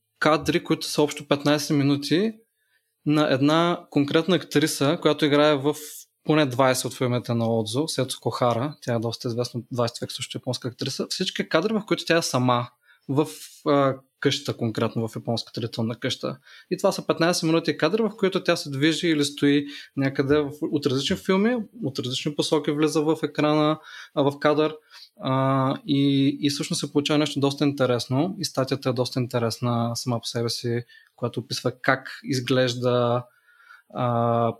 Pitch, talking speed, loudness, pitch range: 140 Hz, 155 wpm, -24 LUFS, 125-155 Hz